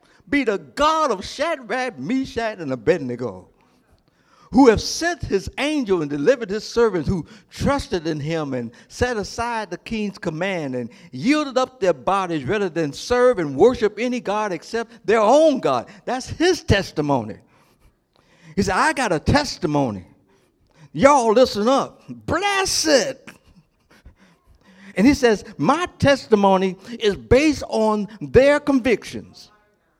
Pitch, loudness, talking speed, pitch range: 215 Hz, -20 LUFS, 135 wpm, 175-255 Hz